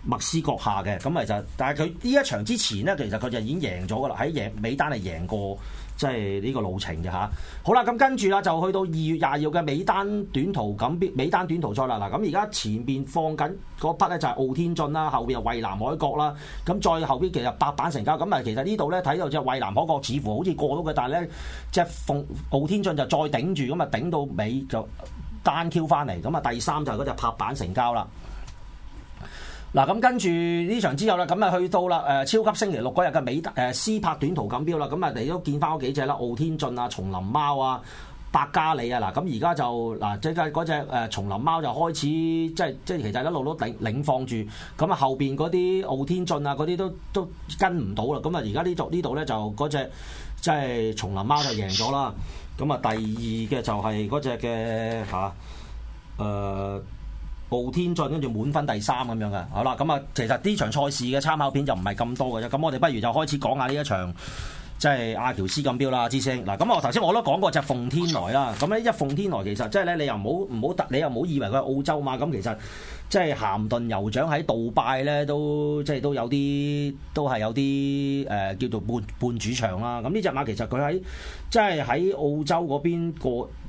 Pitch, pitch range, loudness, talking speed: 140 Hz, 110-160 Hz, -26 LUFS, 320 characters per minute